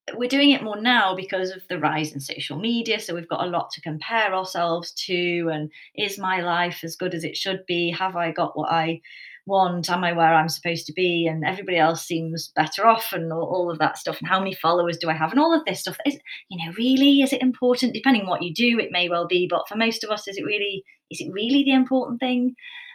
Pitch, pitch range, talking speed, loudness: 180 Hz, 165-230 Hz, 255 wpm, -22 LUFS